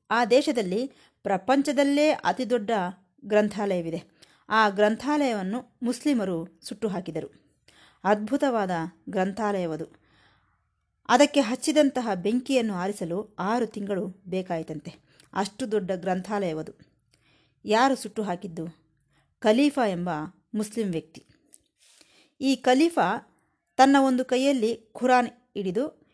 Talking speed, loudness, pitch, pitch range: 85 wpm, -26 LUFS, 210 Hz, 180-255 Hz